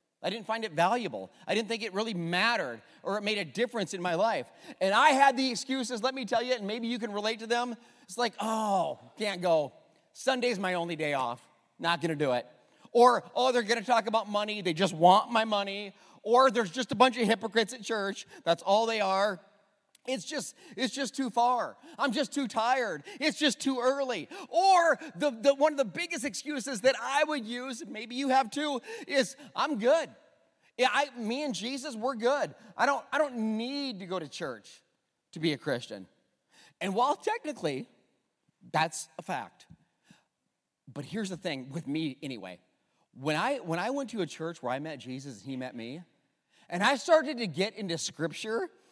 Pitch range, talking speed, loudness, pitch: 185-265 Hz, 200 wpm, -30 LUFS, 225 Hz